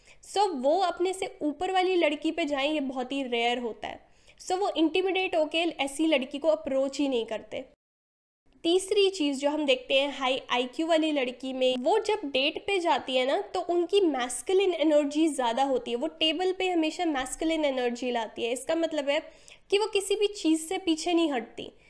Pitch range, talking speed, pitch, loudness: 265-360 Hz, 200 wpm, 310 Hz, -27 LUFS